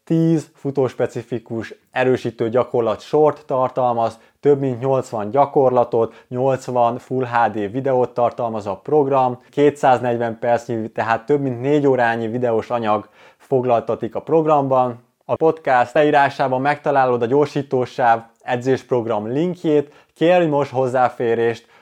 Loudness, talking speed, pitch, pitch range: -19 LUFS, 110 wpm, 125 Hz, 120-140 Hz